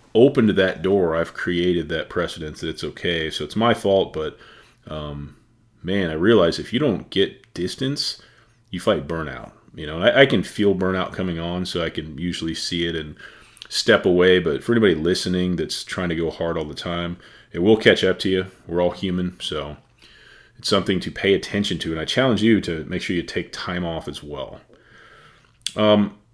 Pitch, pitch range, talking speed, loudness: 90 Hz, 85-100 Hz, 200 wpm, -21 LUFS